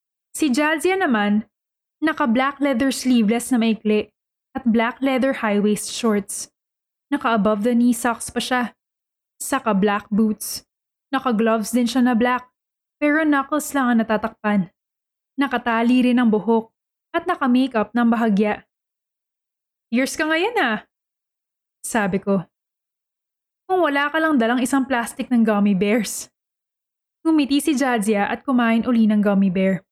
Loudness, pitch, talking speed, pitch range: -20 LUFS, 245 Hz, 140 wpm, 215-275 Hz